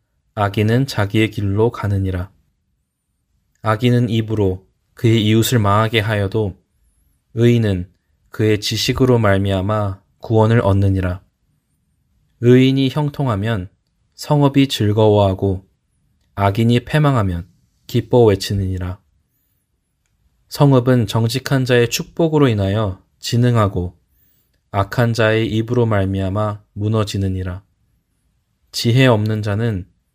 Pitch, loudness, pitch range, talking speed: 105 Hz, -17 LUFS, 95-120 Hz, 240 characters per minute